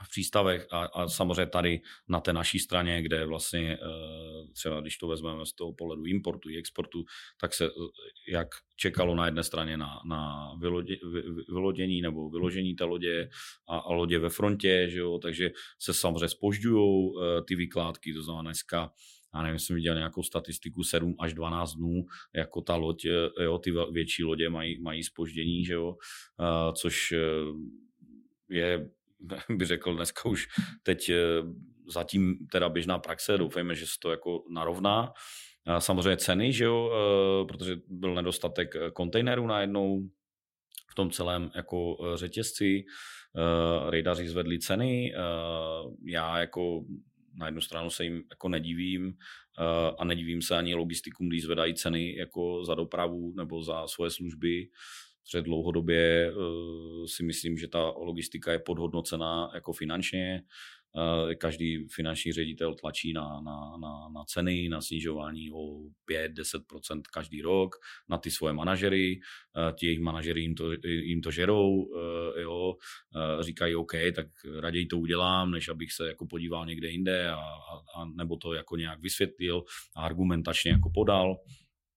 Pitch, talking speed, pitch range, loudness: 85 Hz, 150 wpm, 80-90 Hz, -31 LUFS